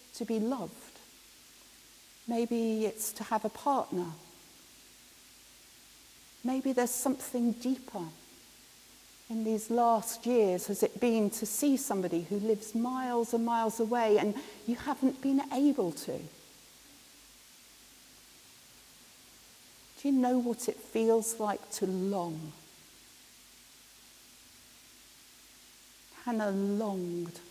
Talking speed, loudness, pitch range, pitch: 100 wpm, -32 LUFS, 210-245 Hz, 230 Hz